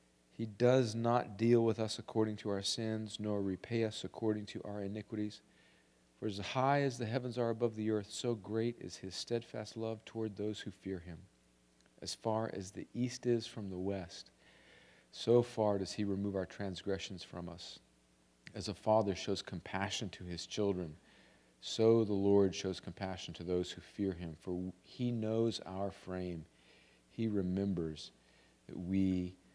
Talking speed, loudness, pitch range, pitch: 170 wpm, -37 LUFS, 90-110 Hz, 100 Hz